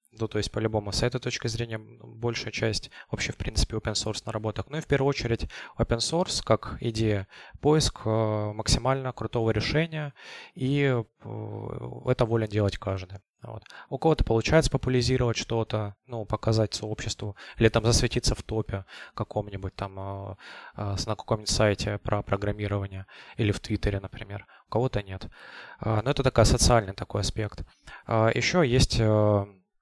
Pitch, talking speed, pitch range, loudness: 110 Hz, 145 wpm, 105-120 Hz, -27 LUFS